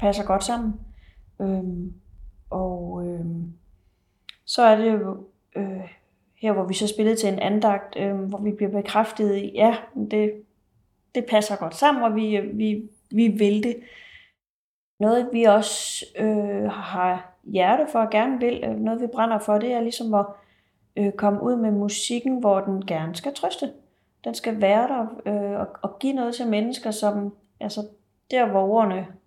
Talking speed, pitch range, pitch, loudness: 170 wpm, 195-225 Hz, 210 Hz, -23 LUFS